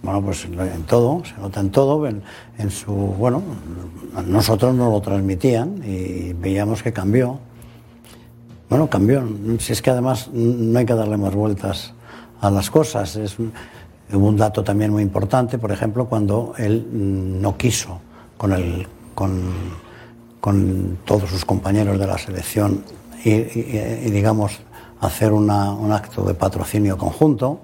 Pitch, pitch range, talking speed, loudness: 105 Hz, 100-115 Hz, 155 wpm, -20 LUFS